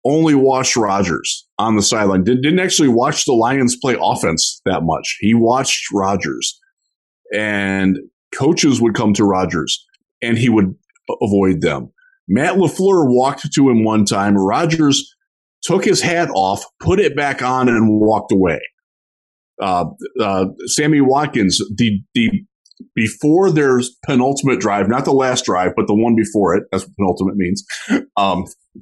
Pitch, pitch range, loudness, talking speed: 125 Hz, 105-150 Hz, -15 LUFS, 150 wpm